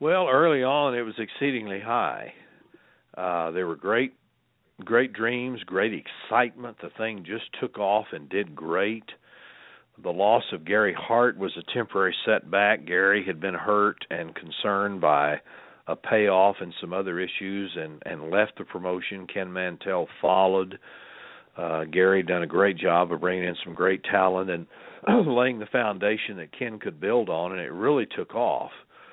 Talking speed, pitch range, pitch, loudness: 165 wpm, 90-110 Hz, 95 Hz, -25 LUFS